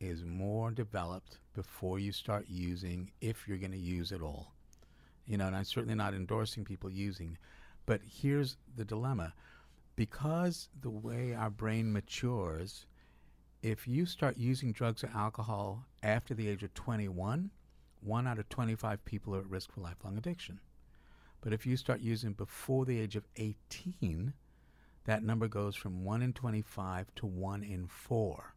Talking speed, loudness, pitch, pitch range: 160 wpm, -38 LUFS, 105 Hz, 95-115 Hz